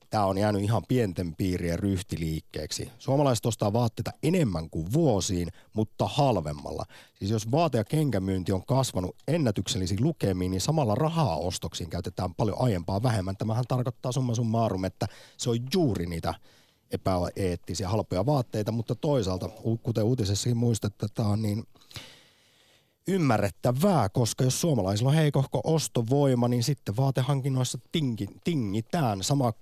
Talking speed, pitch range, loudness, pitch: 130 wpm, 95-135 Hz, -28 LUFS, 115 Hz